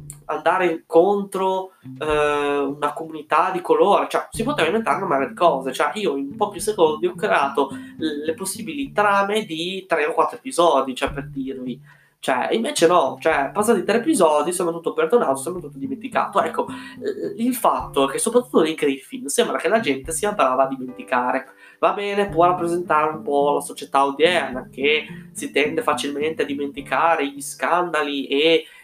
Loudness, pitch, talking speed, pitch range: -21 LUFS, 165 Hz, 165 wpm, 145-210 Hz